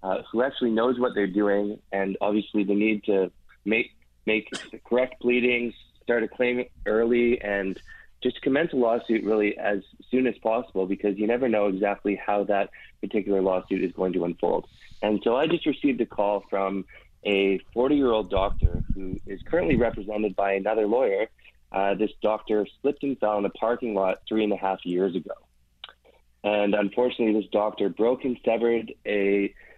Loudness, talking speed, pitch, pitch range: -25 LUFS, 175 wpm, 105 Hz, 95-115 Hz